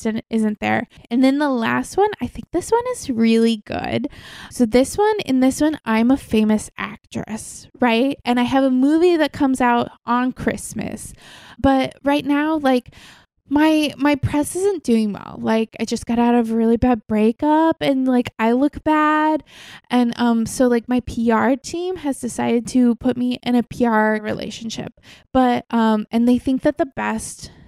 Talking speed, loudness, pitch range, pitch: 180 wpm, -19 LUFS, 230-285 Hz, 245 Hz